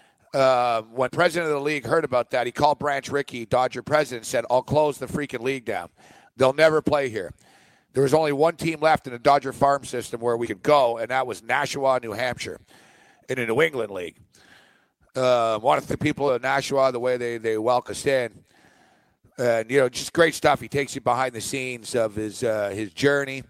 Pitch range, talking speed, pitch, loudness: 120-145 Hz, 215 wpm, 130 Hz, -23 LUFS